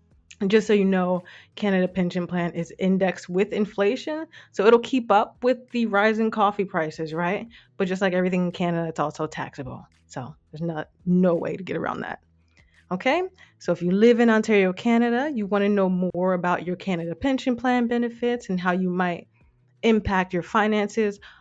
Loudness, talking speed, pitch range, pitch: -23 LUFS, 185 wpm, 175-220 Hz, 190 Hz